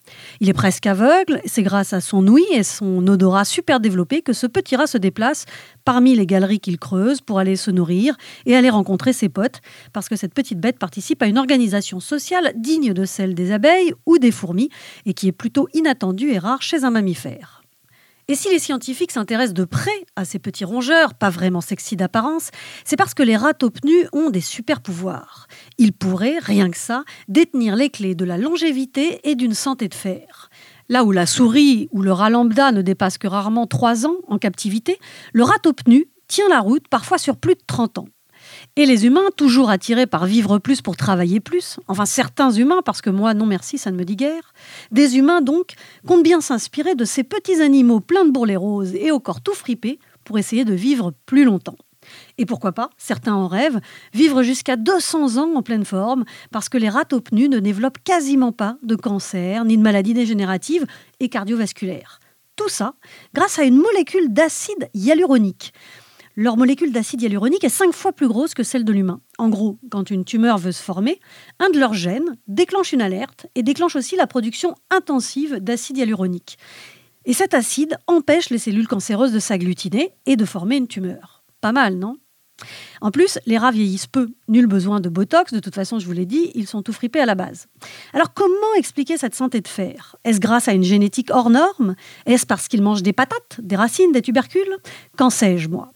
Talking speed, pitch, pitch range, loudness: 200 wpm, 240 Hz, 200-290 Hz, -18 LUFS